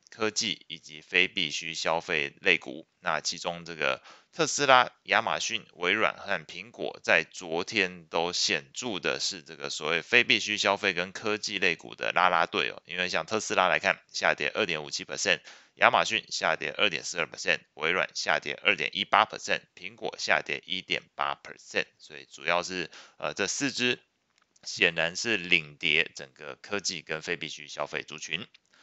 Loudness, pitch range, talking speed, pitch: -27 LUFS, 85-110 Hz, 305 characters per minute, 90 Hz